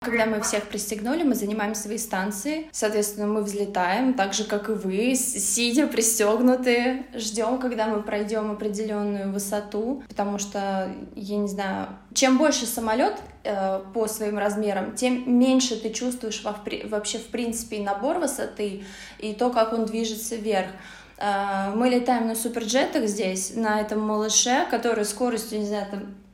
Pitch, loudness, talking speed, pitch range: 215 Hz, -25 LUFS, 150 wpm, 205-240 Hz